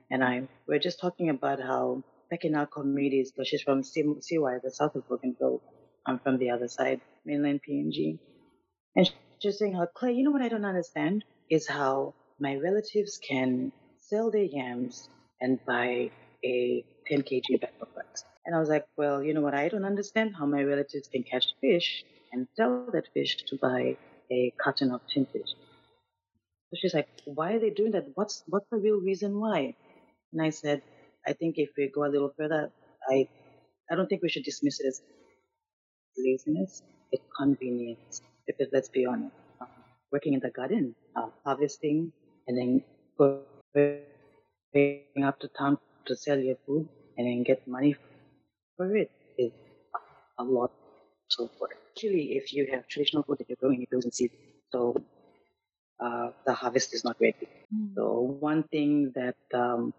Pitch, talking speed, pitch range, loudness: 140 Hz, 175 wpm, 130-165 Hz, -30 LUFS